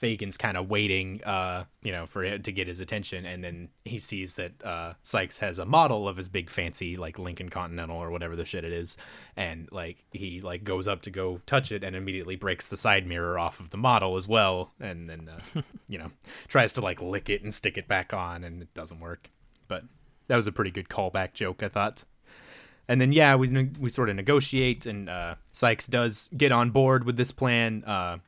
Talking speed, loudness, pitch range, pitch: 225 wpm, -27 LUFS, 90-115 Hz, 95 Hz